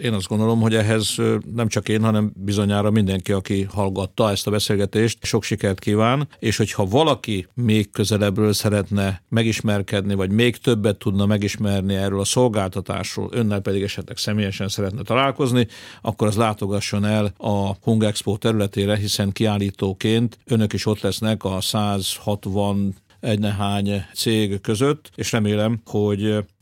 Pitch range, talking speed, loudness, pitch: 100-110 Hz, 140 wpm, -21 LUFS, 105 Hz